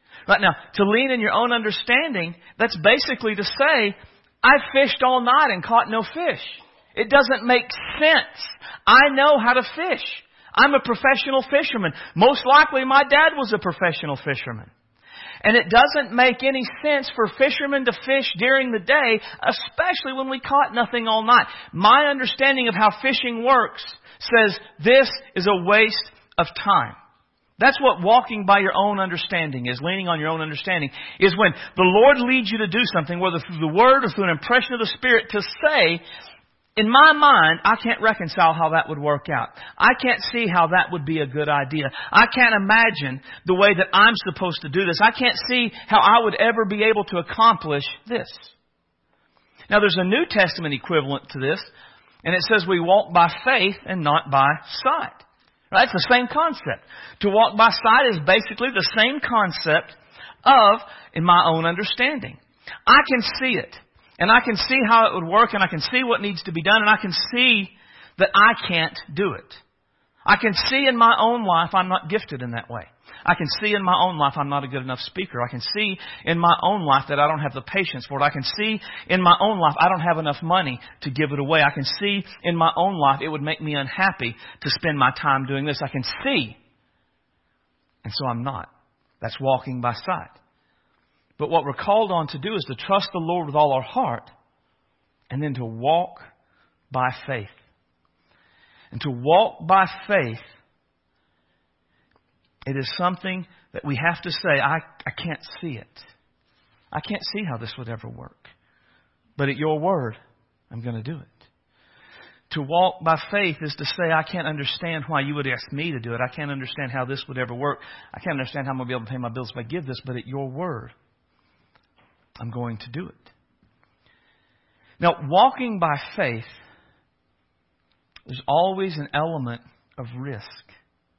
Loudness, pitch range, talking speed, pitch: -19 LUFS, 140-225 Hz, 195 wpm, 180 Hz